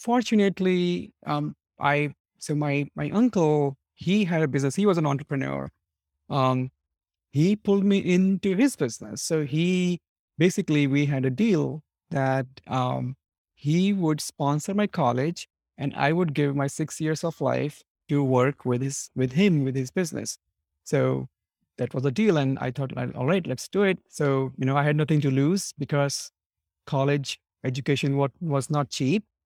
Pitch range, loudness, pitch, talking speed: 130-175 Hz, -25 LUFS, 145 Hz, 165 wpm